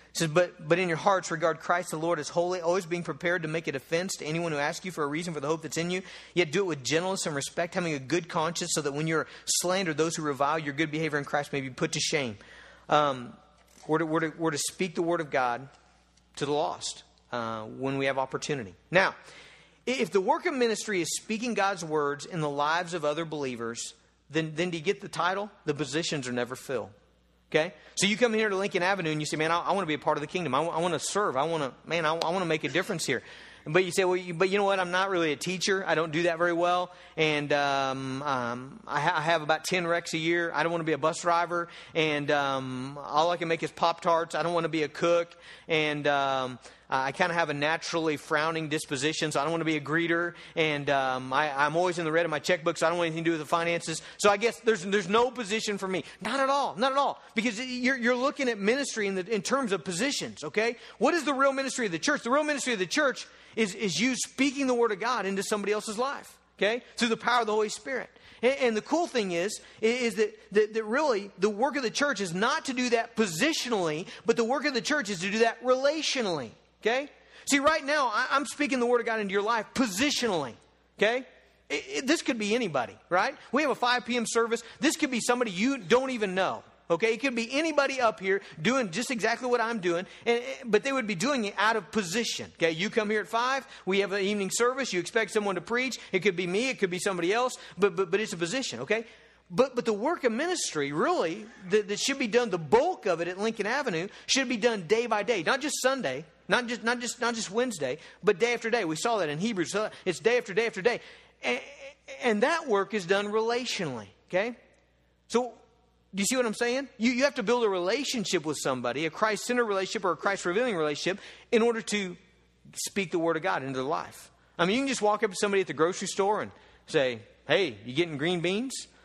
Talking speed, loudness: 250 wpm, -28 LUFS